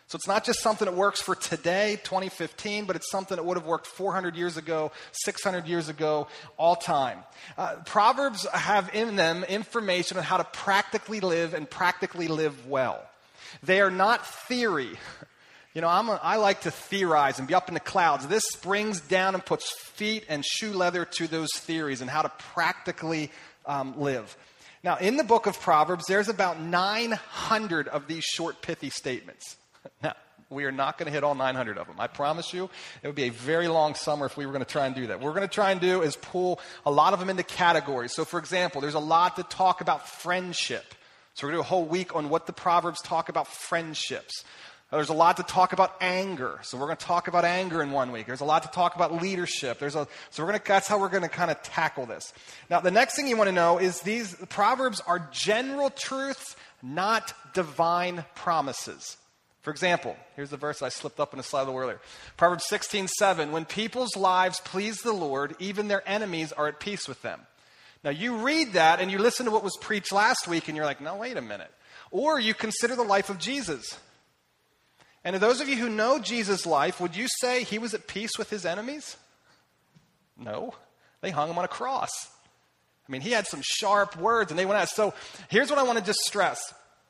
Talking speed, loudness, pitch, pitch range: 220 wpm, -27 LUFS, 180 Hz, 160-205 Hz